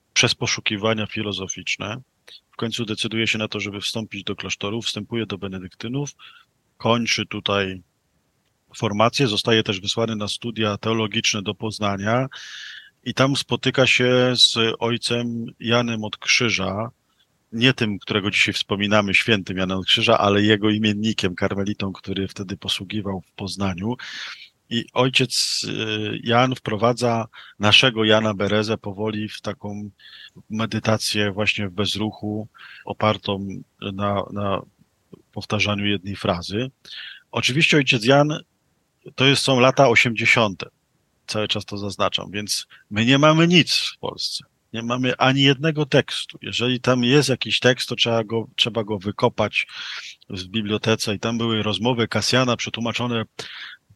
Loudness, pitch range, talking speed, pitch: -21 LUFS, 105-120 Hz, 130 wpm, 110 Hz